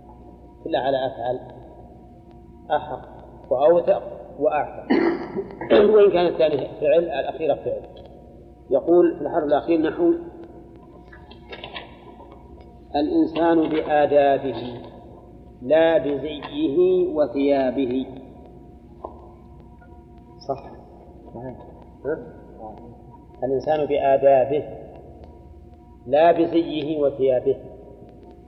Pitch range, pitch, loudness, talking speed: 120-170 Hz, 145 Hz, -21 LUFS, 60 wpm